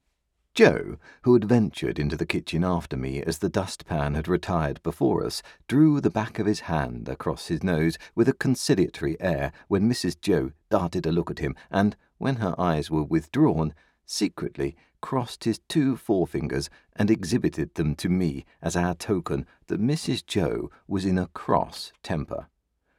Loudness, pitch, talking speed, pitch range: -26 LUFS, 85 Hz, 165 wpm, 75-105 Hz